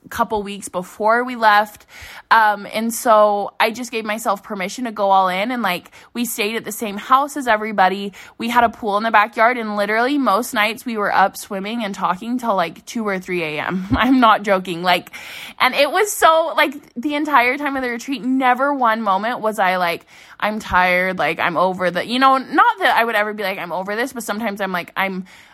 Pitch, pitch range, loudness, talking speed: 215 Hz, 195-245 Hz, -18 LUFS, 220 wpm